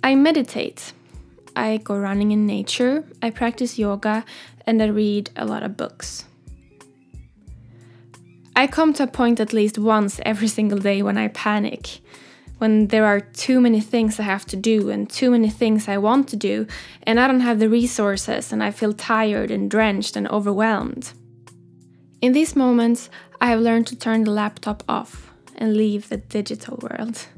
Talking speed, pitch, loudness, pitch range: 175 wpm, 220 Hz, -20 LUFS, 205-235 Hz